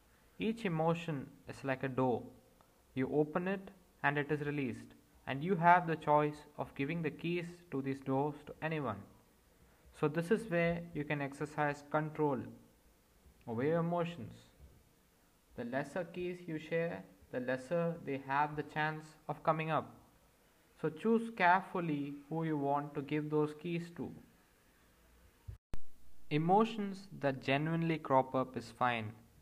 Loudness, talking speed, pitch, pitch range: -36 LUFS, 145 wpm, 150 Hz, 135-170 Hz